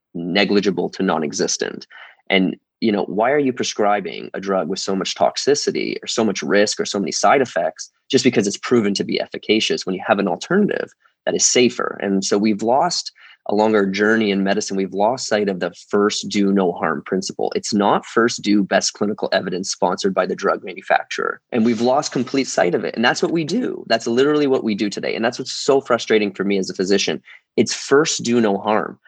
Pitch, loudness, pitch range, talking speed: 105 Hz, -19 LUFS, 100-125 Hz, 215 wpm